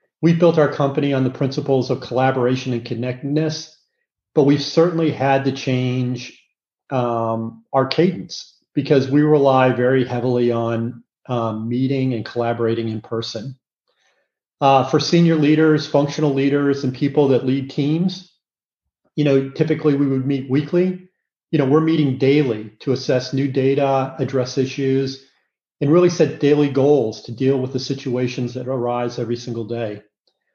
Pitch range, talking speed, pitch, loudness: 125-145 Hz, 150 wpm, 135 Hz, -19 LUFS